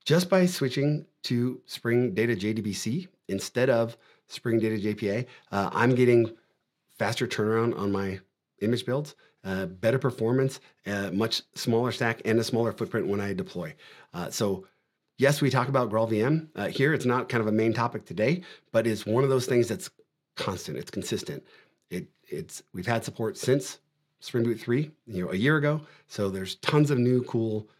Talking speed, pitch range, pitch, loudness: 175 wpm, 110-135 Hz, 120 Hz, -27 LUFS